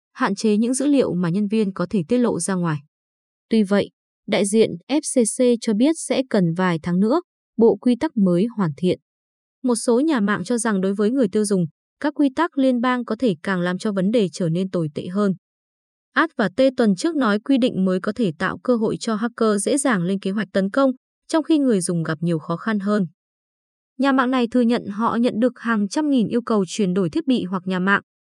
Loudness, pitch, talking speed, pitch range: -21 LUFS, 220 Hz, 240 wpm, 190-250 Hz